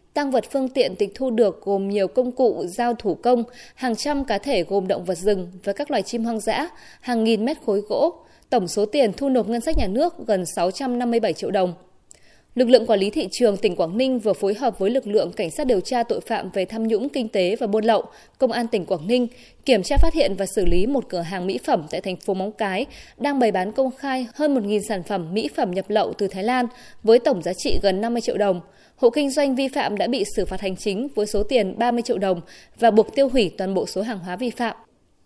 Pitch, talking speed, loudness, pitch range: 225 Hz, 255 wpm, -22 LUFS, 195-255 Hz